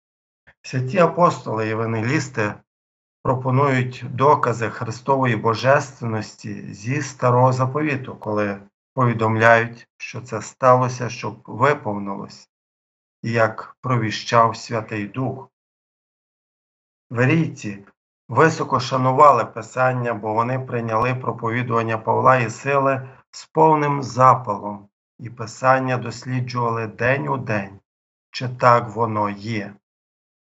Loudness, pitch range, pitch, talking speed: -20 LUFS, 105-130 Hz, 115 Hz, 90 wpm